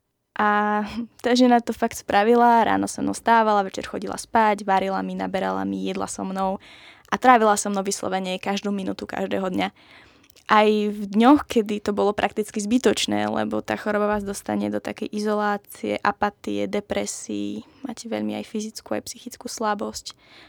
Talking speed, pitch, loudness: 160 wpm, 205 Hz, -23 LUFS